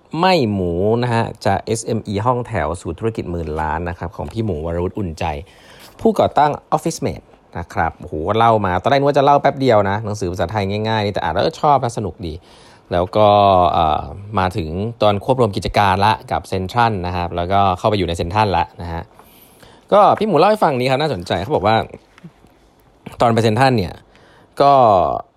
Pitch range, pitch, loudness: 90-115 Hz, 105 Hz, -17 LUFS